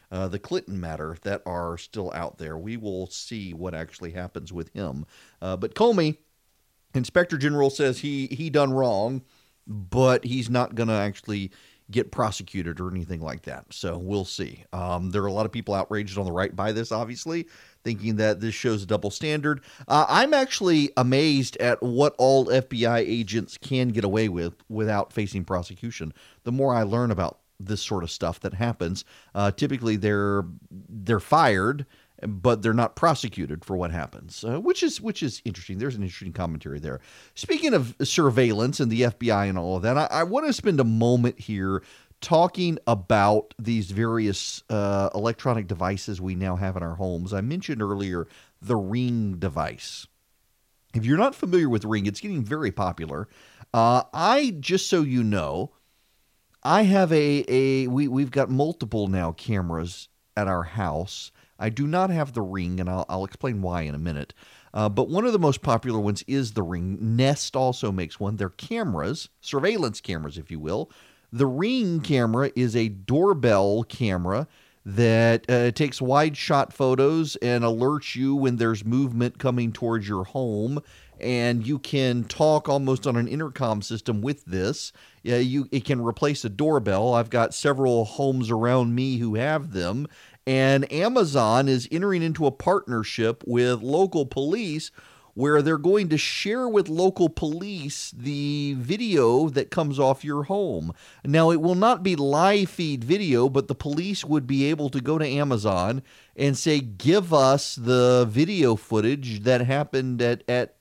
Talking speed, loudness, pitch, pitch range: 170 wpm, -24 LUFS, 120 Hz, 100-140 Hz